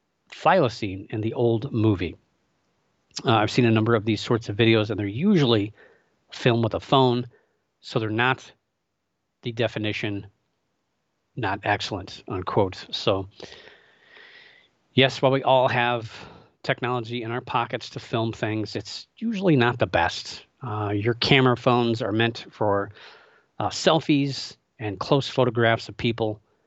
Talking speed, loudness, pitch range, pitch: 140 wpm, -24 LUFS, 110-130 Hz, 120 Hz